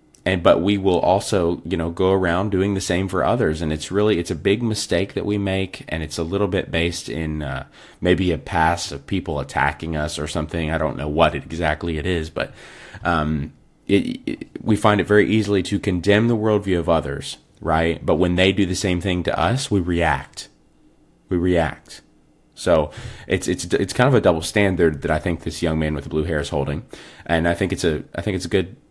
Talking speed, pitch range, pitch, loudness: 225 wpm, 80-95 Hz, 85 Hz, -21 LUFS